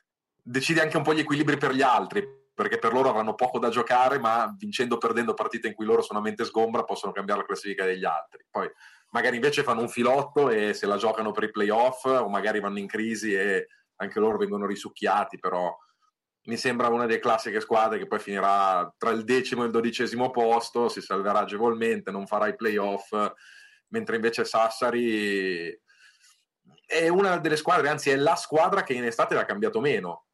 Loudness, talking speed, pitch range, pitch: -26 LUFS, 195 wpm, 110-155 Hz, 120 Hz